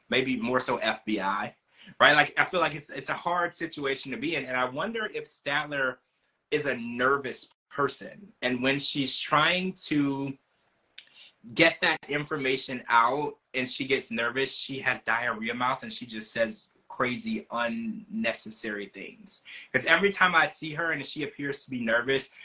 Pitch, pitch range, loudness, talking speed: 135 Hz, 125-165 Hz, -27 LUFS, 165 wpm